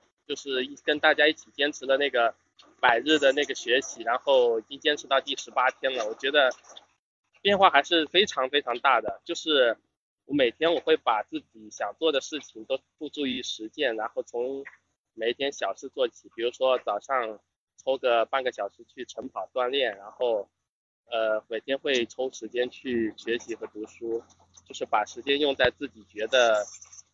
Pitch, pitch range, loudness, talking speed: 140 Hz, 120-200 Hz, -26 LUFS, 260 characters per minute